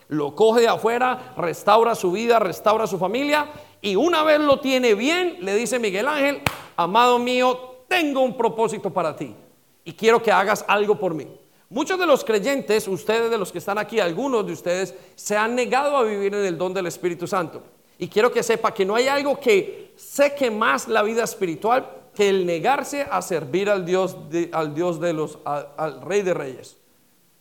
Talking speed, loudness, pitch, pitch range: 190 wpm, -21 LUFS, 215 Hz, 185-255 Hz